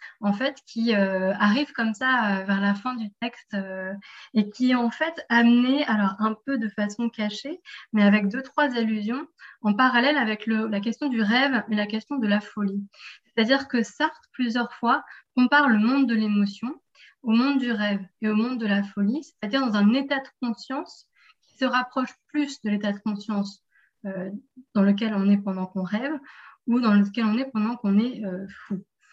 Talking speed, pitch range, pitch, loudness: 200 wpm, 205-260 Hz, 225 Hz, -24 LUFS